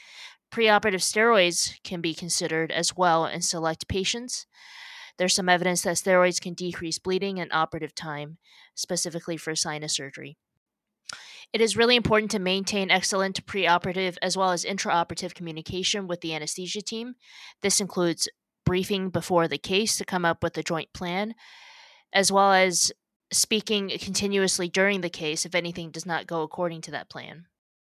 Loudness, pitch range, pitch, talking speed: -25 LUFS, 165-200 Hz, 180 Hz, 155 wpm